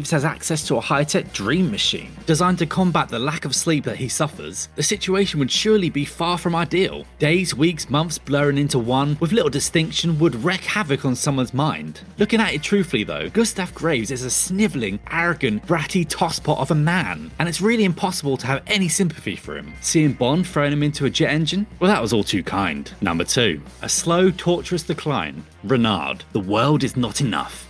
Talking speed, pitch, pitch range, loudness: 200 wpm, 160 Hz, 140-185 Hz, -20 LUFS